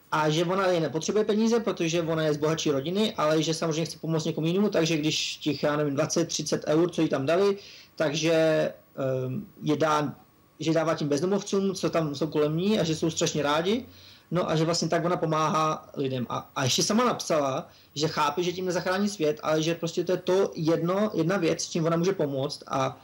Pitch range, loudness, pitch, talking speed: 155-180 Hz, -26 LUFS, 160 Hz, 210 wpm